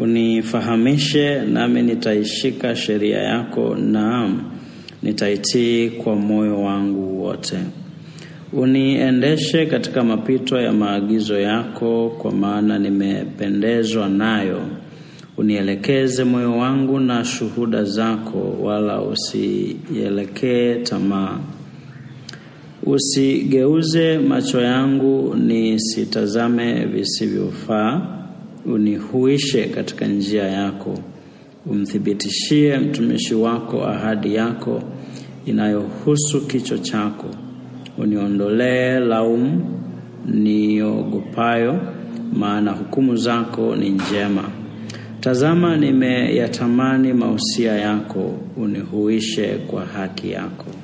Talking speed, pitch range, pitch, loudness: 75 wpm, 105-130 Hz, 115 Hz, -19 LUFS